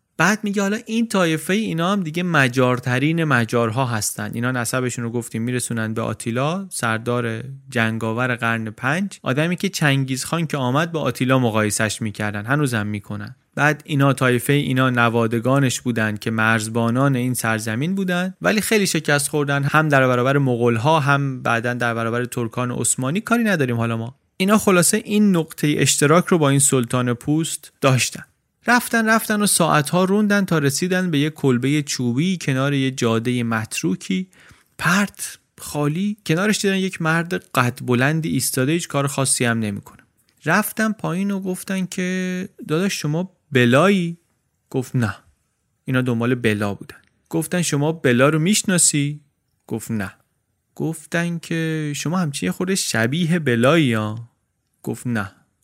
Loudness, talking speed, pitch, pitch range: -20 LUFS, 145 wpm, 140 Hz, 120-175 Hz